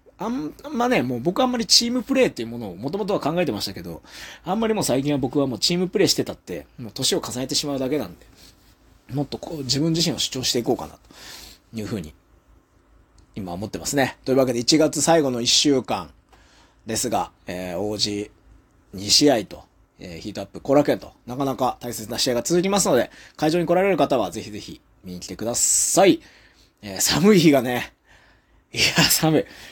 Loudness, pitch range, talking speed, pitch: -21 LUFS, 105-165 Hz, 380 characters per minute, 130 Hz